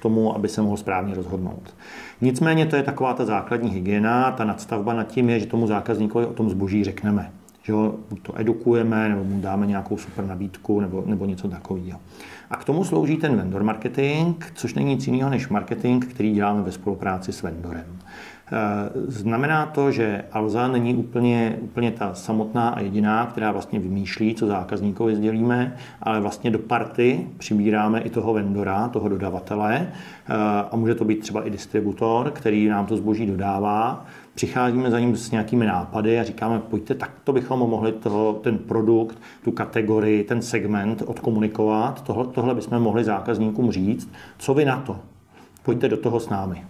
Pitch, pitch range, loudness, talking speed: 110 Hz, 105-120 Hz, -23 LUFS, 170 wpm